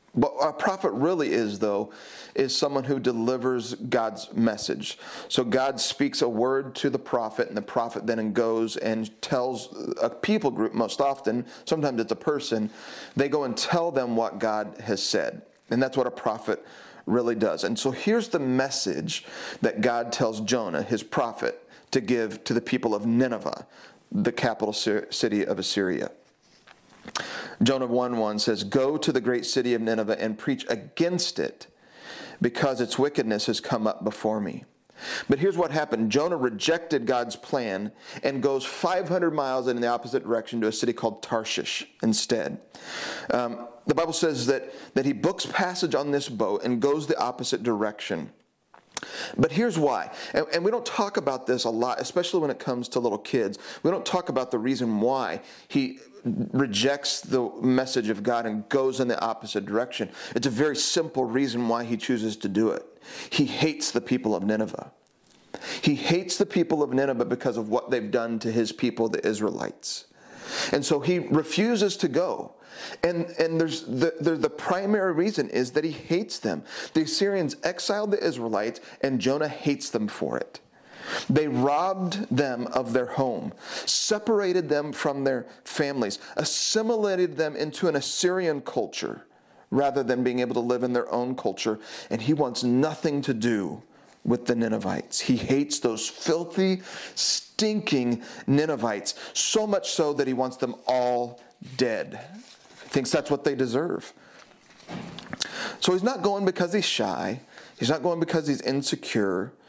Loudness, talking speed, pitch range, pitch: -26 LUFS, 170 wpm, 120-160 Hz, 135 Hz